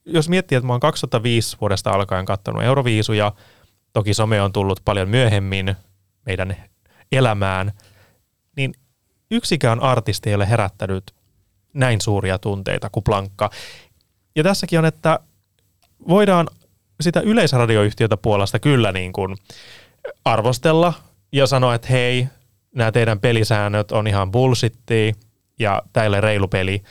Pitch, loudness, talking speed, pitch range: 110 Hz, -19 LUFS, 125 wpm, 100-130 Hz